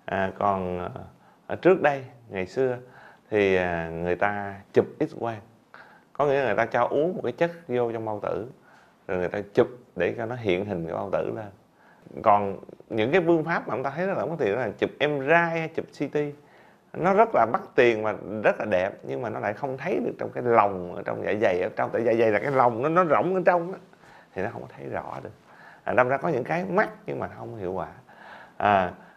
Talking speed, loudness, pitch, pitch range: 235 wpm, -25 LUFS, 120 Hz, 100-155 Hz